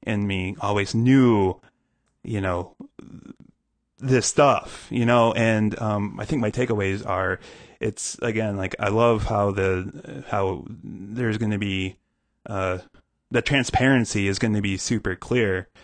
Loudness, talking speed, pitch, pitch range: -23 LUFS, 145 wpm, 105 Hz, 95-115 Hz